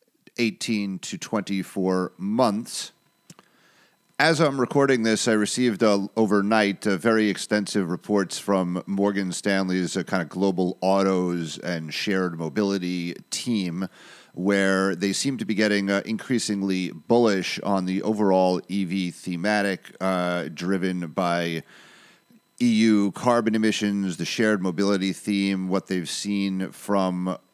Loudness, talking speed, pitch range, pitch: -24 LUFS, 120 wpm, 95-110 Hz, 100 Hz